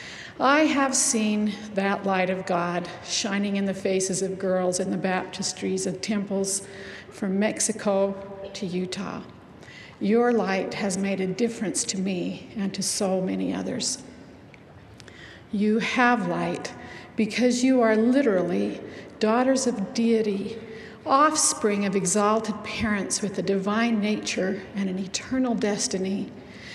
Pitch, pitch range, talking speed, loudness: 205 Hz, 190-225 Hz, 130 wpm, -25 LUFS